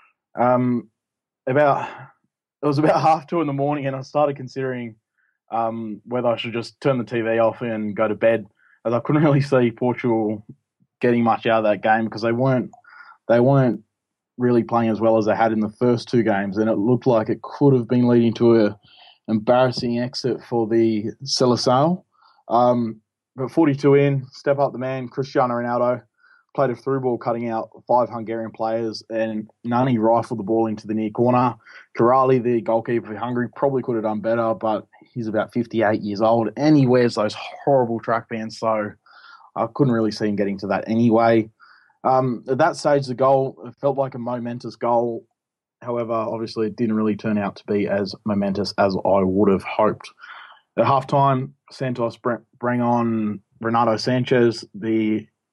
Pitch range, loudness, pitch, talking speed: 110-130 Hz, -21 LUFS, 120 Hz, 185 wpm